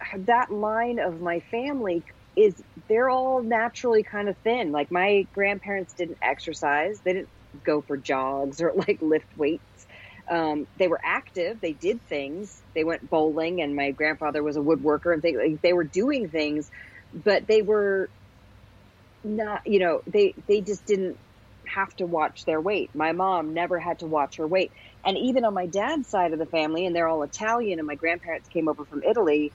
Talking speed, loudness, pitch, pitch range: 185 wpm, -25 LUFS, 170 Hz, 150-205 Hz